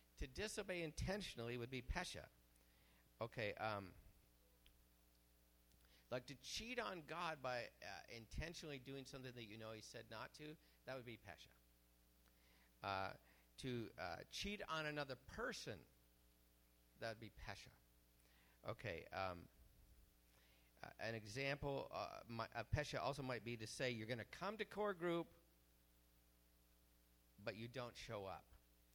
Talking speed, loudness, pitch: 135 wpm, -50 LUFS, 110 Hz